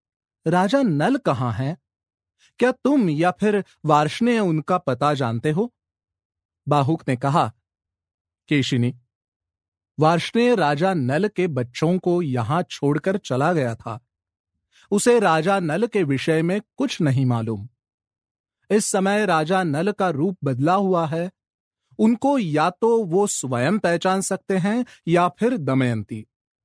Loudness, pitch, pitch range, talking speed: -21 LUFS, 155 Hz, 120-195 Hz, 130 wpm